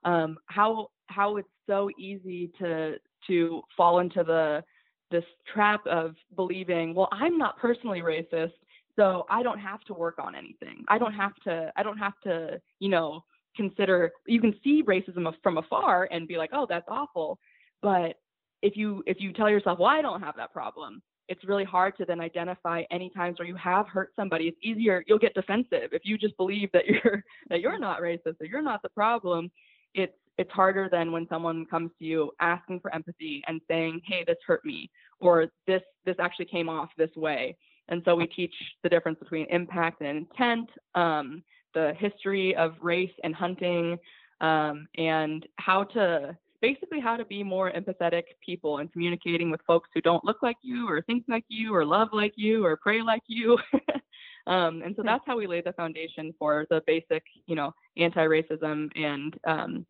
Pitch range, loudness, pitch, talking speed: 165-205 Hz, -28 LUFS, 180 Hz, 190 wpm